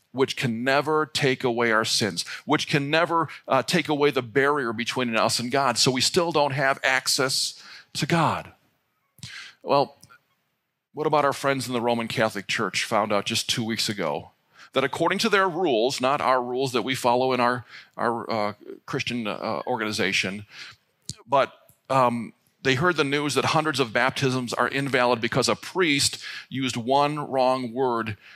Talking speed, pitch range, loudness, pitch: 170 wpm, 120-145 Hz, -24 LUFS, 130 Hz